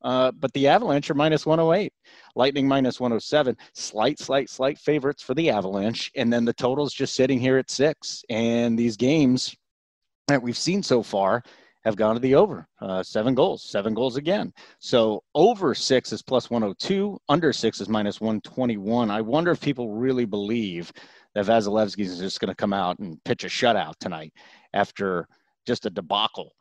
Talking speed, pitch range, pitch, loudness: 180 wpm, 110-135 Hz, 120 Hz, -24 LUFS